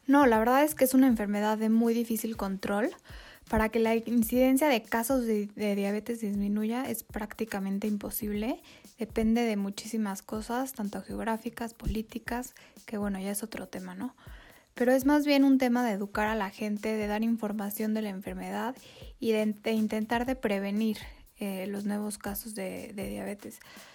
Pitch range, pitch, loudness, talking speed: 210-240 Hz, 220 Hz, -30 LUFS, 175 wpm